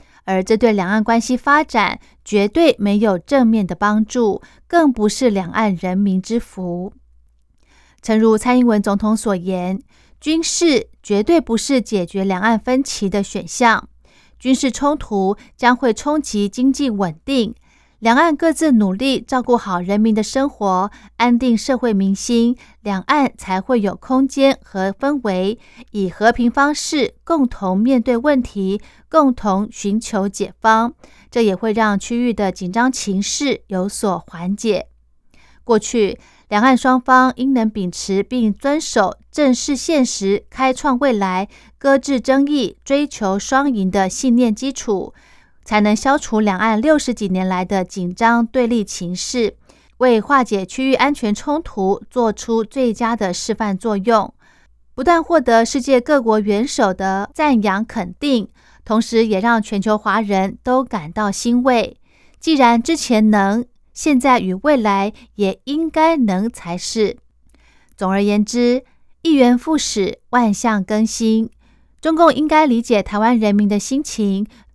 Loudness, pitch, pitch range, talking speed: -17 LUFS, 225 Hz, 200-260 Hz, 210 characters per minute